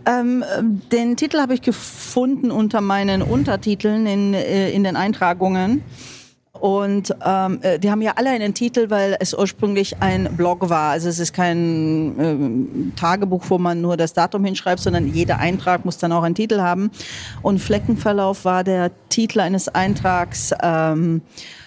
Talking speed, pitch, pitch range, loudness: 155 wpm, 190 Hz, 170-215 Hz, -19 LUFS